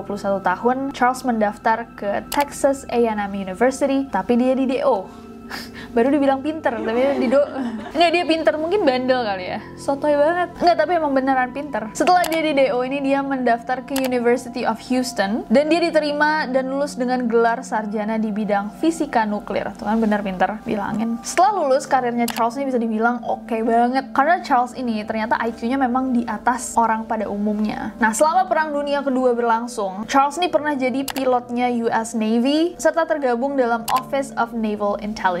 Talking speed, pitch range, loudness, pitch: 170 wpm, 225-275 Hz, -20 LUFS, 250 Hz